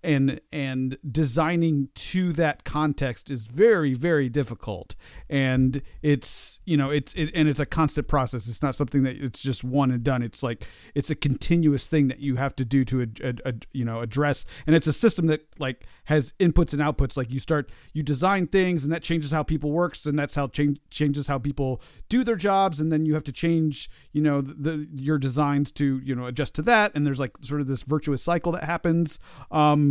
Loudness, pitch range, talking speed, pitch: -24 LUFS, 135-155 Hz, 220 wpm, 145 Hz